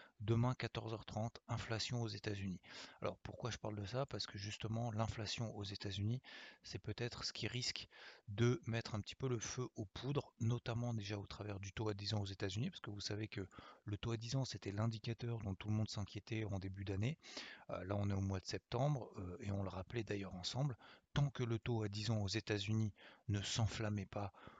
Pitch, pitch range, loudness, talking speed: 110 Hz, 100-115 Hz, -43 LUFS, 210 wpm